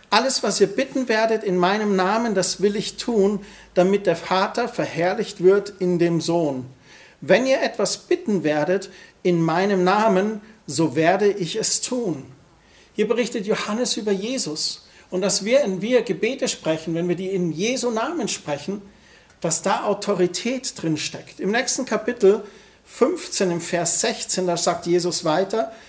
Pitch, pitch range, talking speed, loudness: 195 Hz, 175-220 Hz, 160 wpm, -21 LUFS